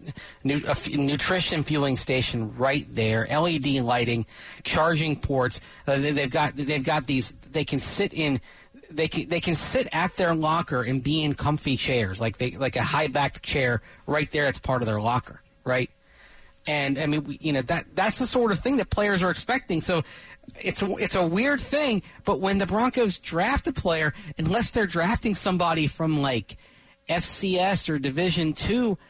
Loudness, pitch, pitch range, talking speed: -24 LUFS, 155 Hz, 135-185 Hz, 175 wpm